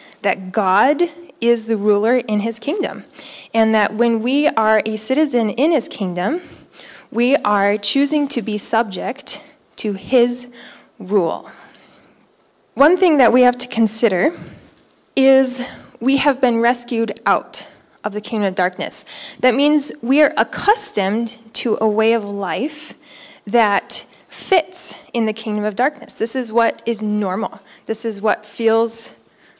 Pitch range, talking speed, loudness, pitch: 215-270 Hz, 145 wpm, -17 LUFS, 230 Hz